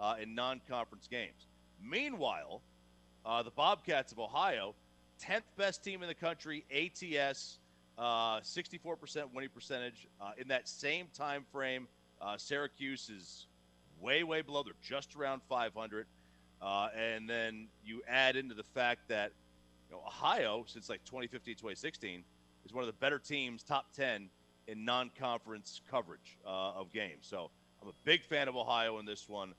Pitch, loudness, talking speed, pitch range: 115 Hz, -38 LUFS, 160 wpm, 90-135 Hz